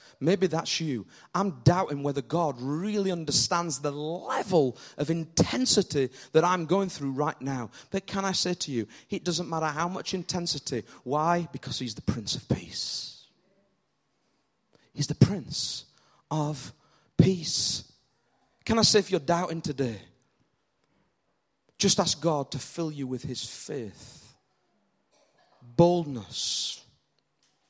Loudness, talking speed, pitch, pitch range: -28 LUFS, 130 wpm, 160 Hz, 135-175 Hz